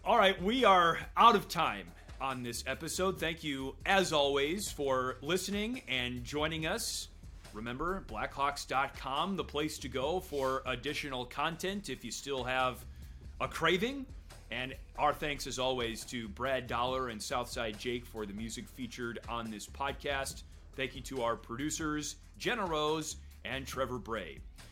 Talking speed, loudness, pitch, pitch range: 150 wpm, -34 LUFS, 130 Hz, 115-155 Hz